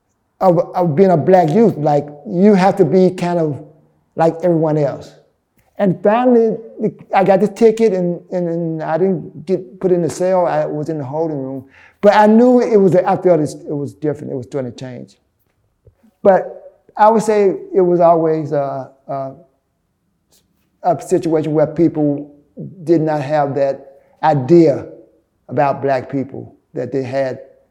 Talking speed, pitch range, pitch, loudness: 165 wpm, 145-190 Hz, 165 Hz, -15 LUFS